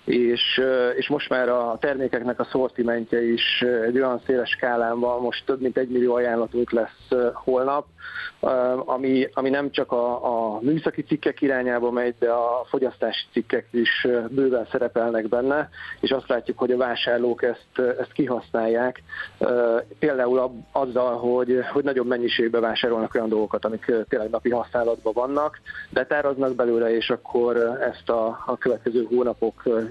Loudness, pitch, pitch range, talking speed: -23 LUFS, 120 Hz, 120-130 Hz, 140 wpm